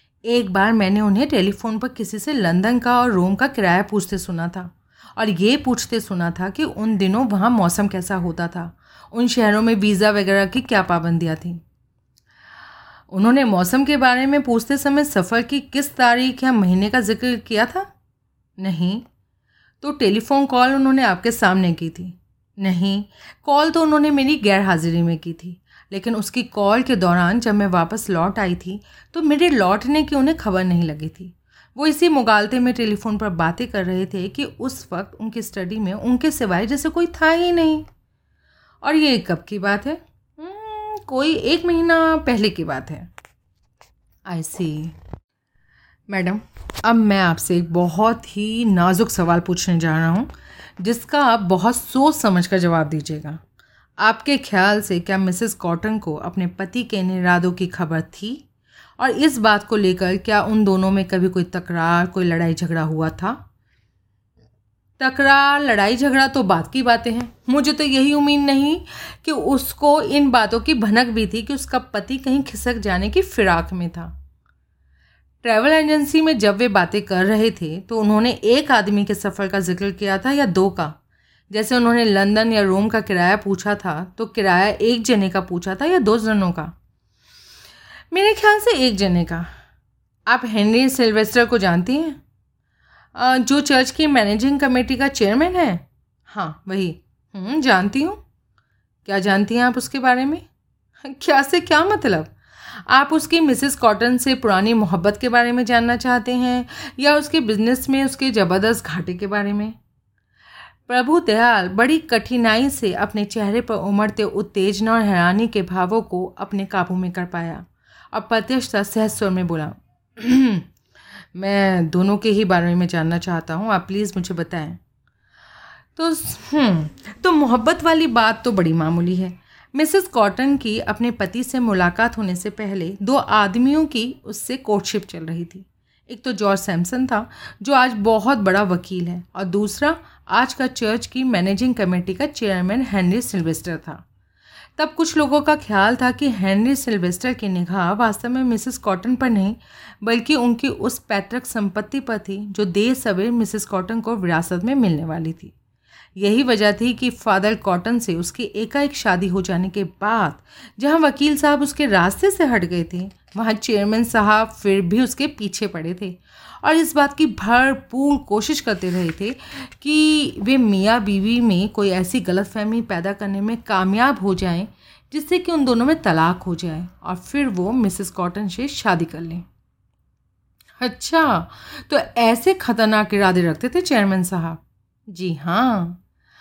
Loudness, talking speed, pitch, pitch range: -18 LUFS, 170 wpm, 215 Hz, 185-255 Hz